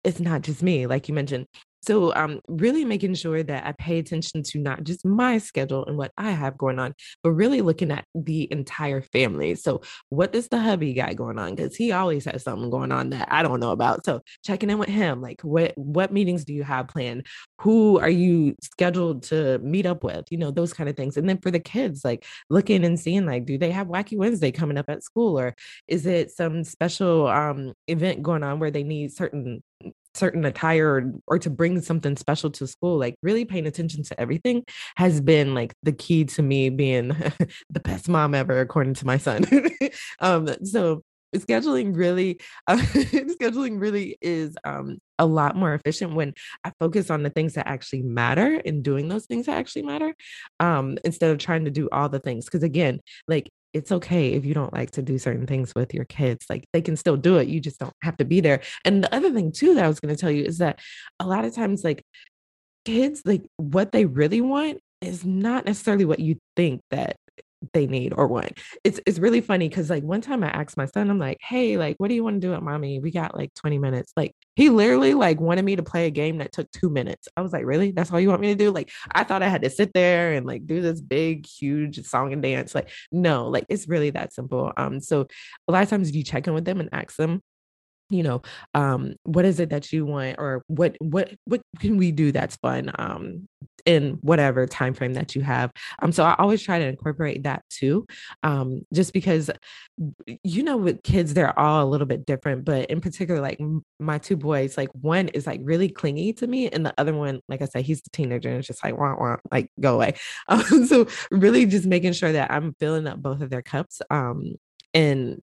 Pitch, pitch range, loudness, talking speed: 160 Hz, 140-185 Hz, -23 LUFS, 230 wpm